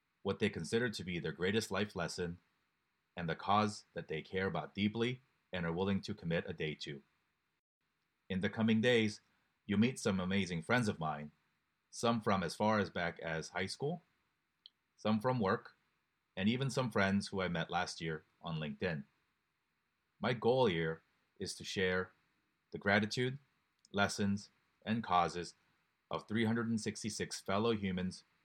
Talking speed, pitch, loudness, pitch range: 155 wpm, 100 Hz, -37 LUFS, 90-115 Hz